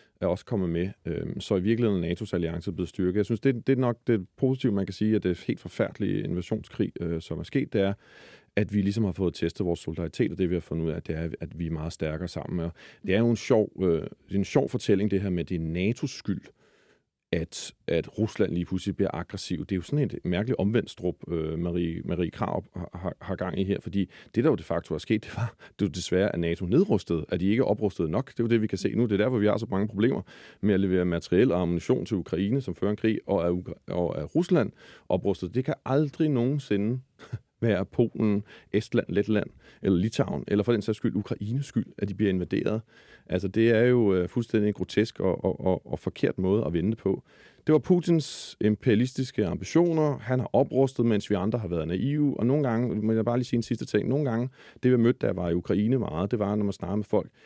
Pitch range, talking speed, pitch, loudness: 90-120 Hz, 240 wpm, 105 Hz, -27 LUFS